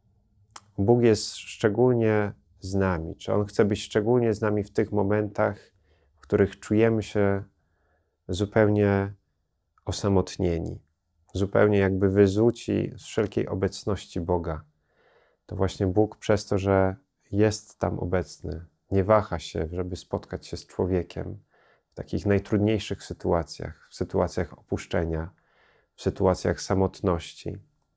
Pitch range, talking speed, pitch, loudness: 90-105 Hz, 120 wpm, 100 Hz, -26 LUFS